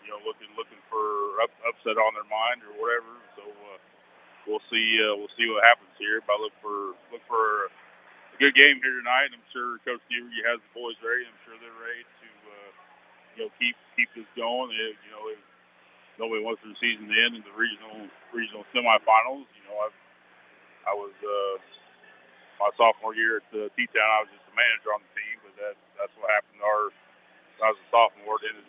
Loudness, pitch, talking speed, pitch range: -25 LUFS, 115 Hz, 205 wpm, 105-125 Hz